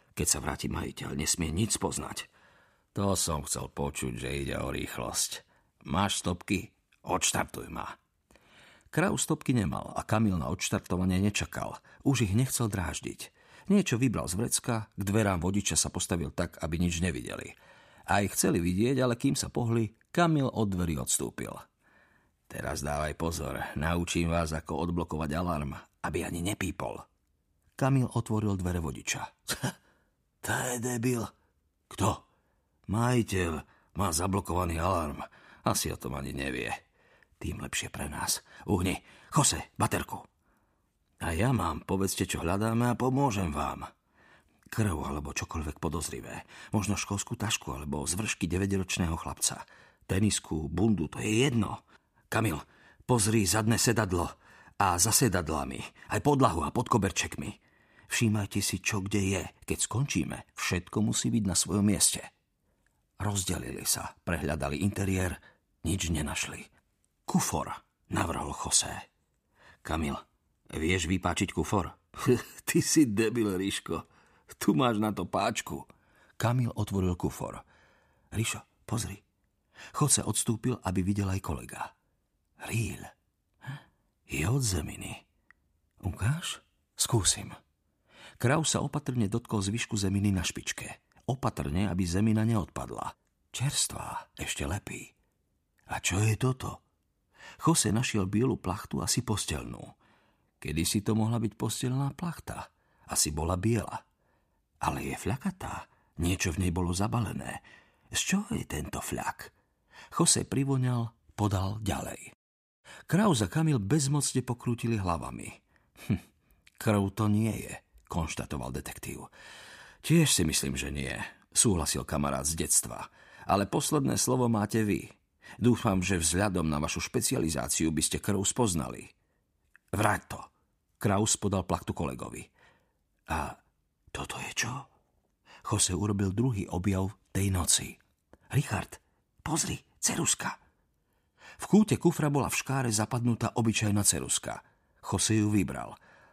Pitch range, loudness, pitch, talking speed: 80-115 Hz, -30 LUFS, 100 Hz, 125 wpm